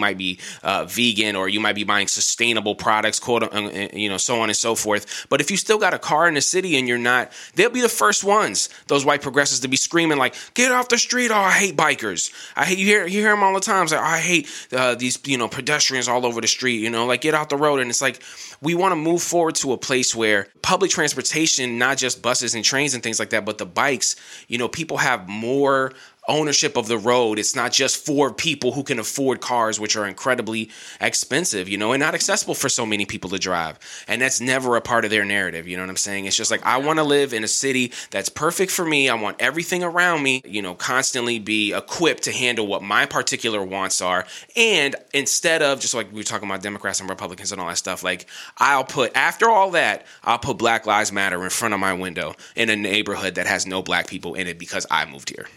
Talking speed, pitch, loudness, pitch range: 250 wpm, 120 Hz, -20 LUFS, 105-150 Hz